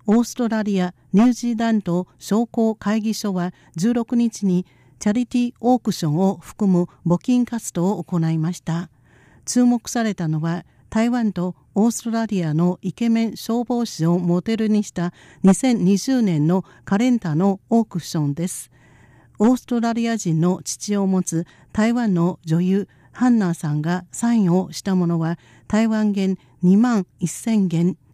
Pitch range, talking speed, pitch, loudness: 170-225 Hz, 285 characters per minute, 195 Hz, -21 LUFS